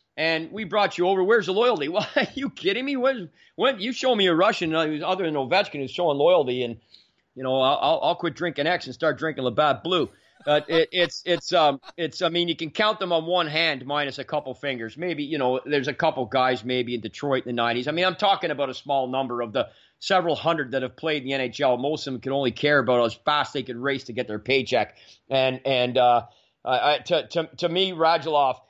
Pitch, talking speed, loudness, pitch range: 150 Hz, 245 wpm, -24 LUFS, 130-175 Hz